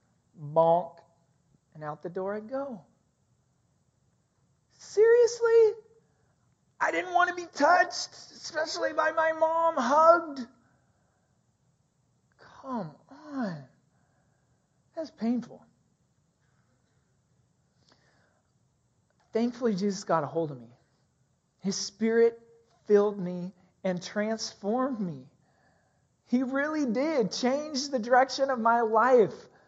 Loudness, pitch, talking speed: -27 LUFS, 220 Hz, 95 wpm